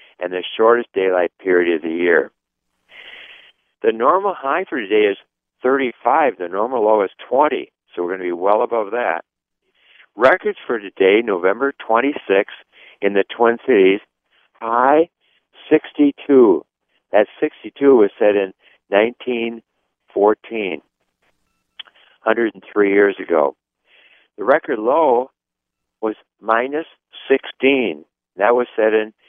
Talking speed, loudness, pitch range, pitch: 120 wpm, -17 LUFS, 95-135 Hz, 110 Hz